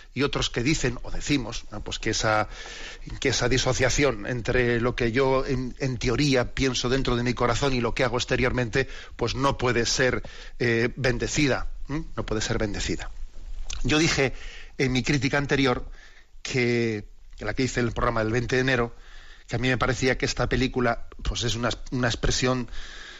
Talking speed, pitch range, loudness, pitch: 185 wpm, 115-130 Hz, -25 LUFS, 125 Hz